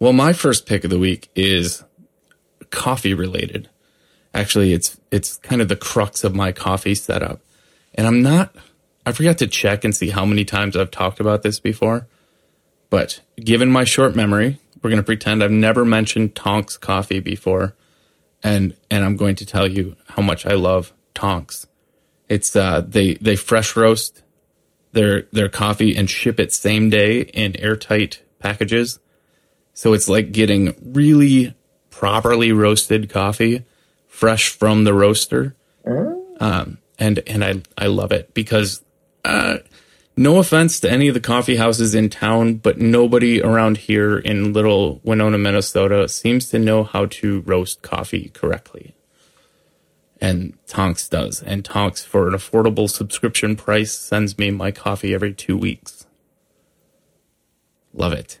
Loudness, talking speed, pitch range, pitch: -17 LUFS, 150 wpm, 100-115 Hz, 105 Hz